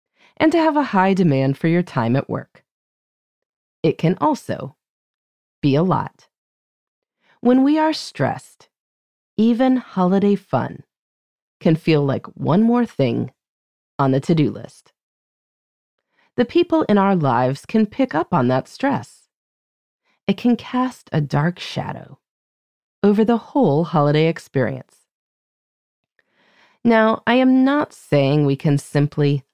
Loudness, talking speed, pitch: -19 LUFS, 130 wpm, 195 Hz